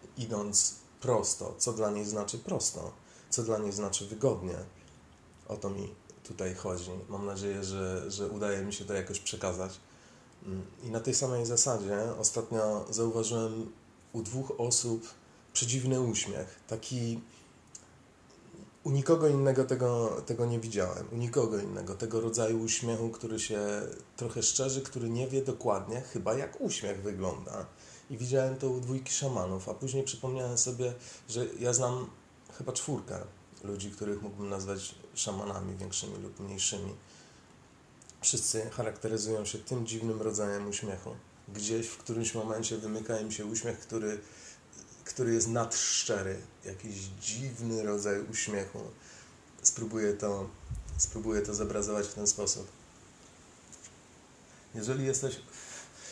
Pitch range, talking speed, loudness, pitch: 100-120 Hz, 130 wpm, -33 LUFS, 110 Hz